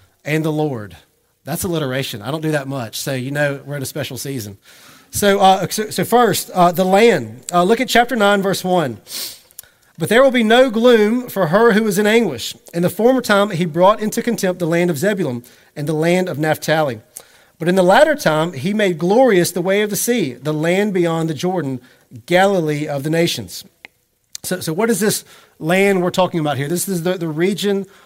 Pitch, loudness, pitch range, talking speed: 180 Hz, -16 LUFS, 150-200 Hz, 210 wpm